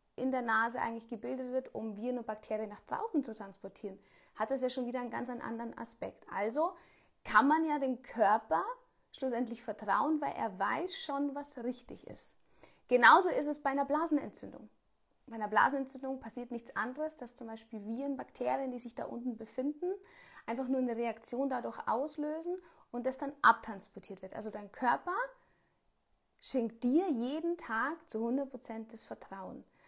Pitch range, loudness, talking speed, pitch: 225-290 Hz, -34 LUFS, 165 wpm, 255 Hz